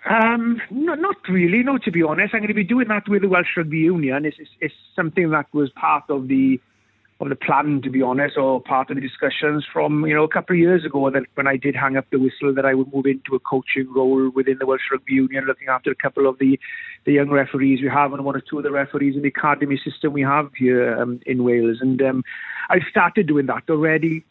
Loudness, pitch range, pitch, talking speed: -20 LUFS, 135-165 Hz, 140 Hz, 250 wpm